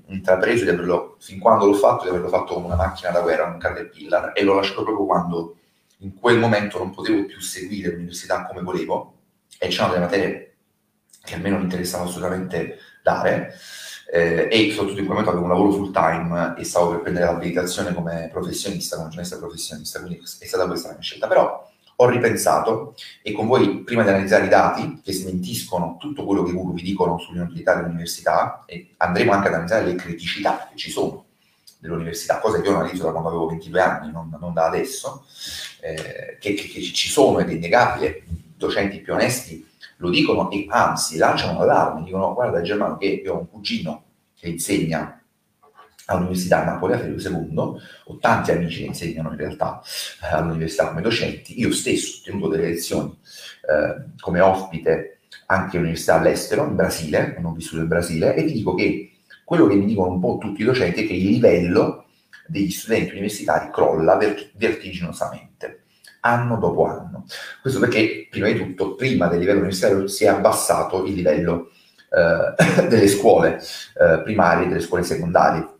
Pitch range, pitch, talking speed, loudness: 85-100 Hz, 90 Hz, 180 wpm, -21 LUFS